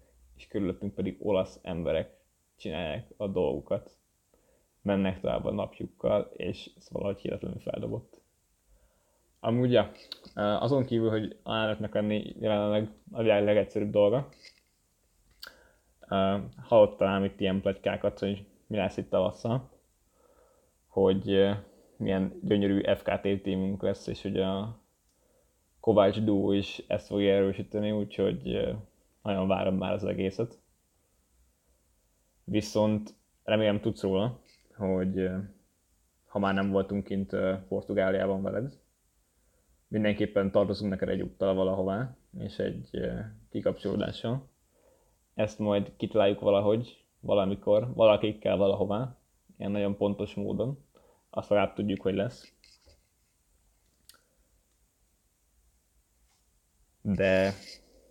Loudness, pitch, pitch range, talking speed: -29 LUFS, 100 Hz, 95-105 Hz, 100 wpm